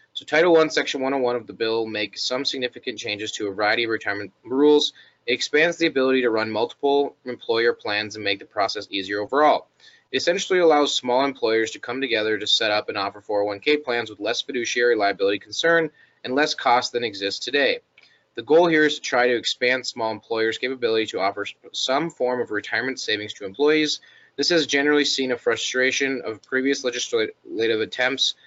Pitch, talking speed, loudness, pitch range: 125 Hz, 190 wpm, -22 LUFS, 110-150 Hz